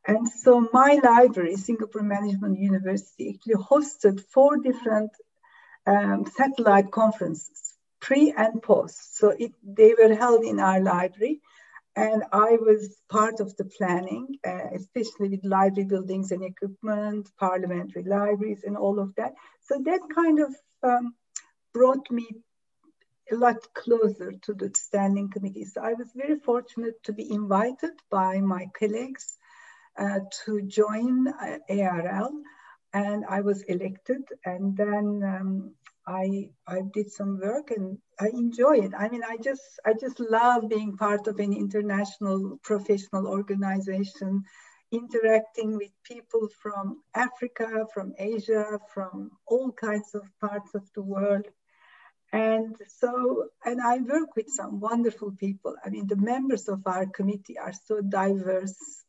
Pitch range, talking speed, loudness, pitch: 195-240 Hz, 140 wpm, -25 LUFS, 210 Hz